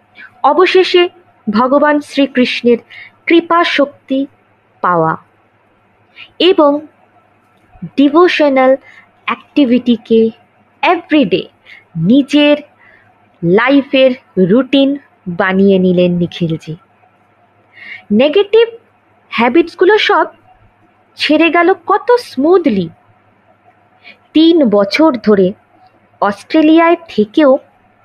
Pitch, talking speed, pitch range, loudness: 275 Hz, 60 wpm, 210-330 Hz, -11 LUFS